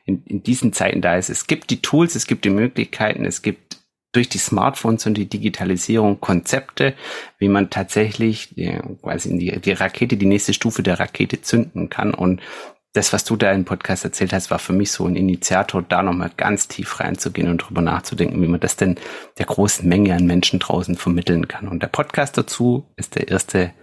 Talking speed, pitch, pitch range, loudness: 200 wpm, 95 Hz, 90-110 Hz, -19 LUFS